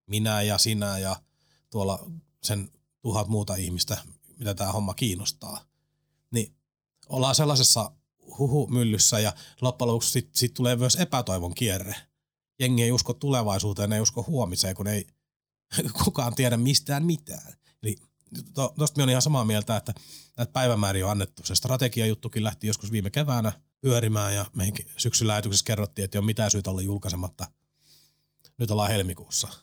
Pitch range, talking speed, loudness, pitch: 100-130 Hz, 150 wpm, -26 LUFS, 110 Hz